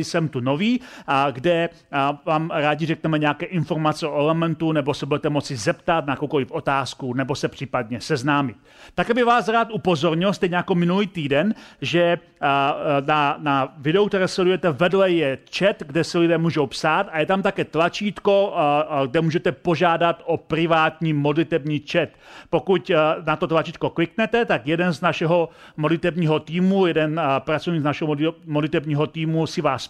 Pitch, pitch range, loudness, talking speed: 165 Hz, 150-175 Hz, -21 LUFS, 155 wpm